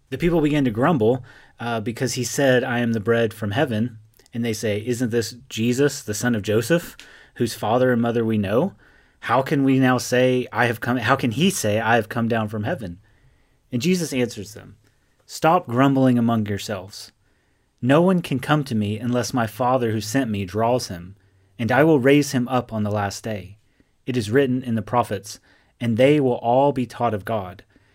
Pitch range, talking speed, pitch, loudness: 110-130 Hz, 205 wpm, 120 Hz, -21 LUFS